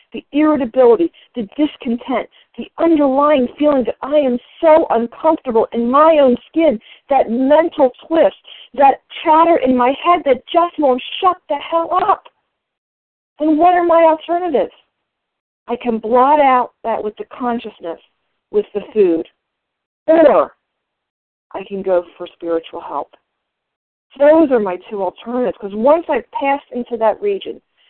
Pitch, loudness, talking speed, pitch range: 280 Hz, -15 LUFS, 140 wpm, 235-320 Hz